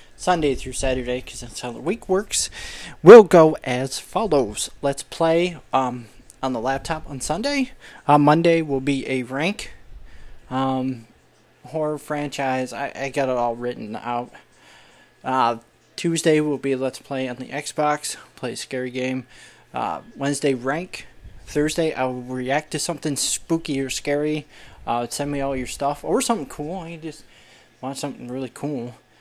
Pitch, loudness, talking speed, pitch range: 135 Hz, -21 LUFS, 160 wpm, 130-155 Hz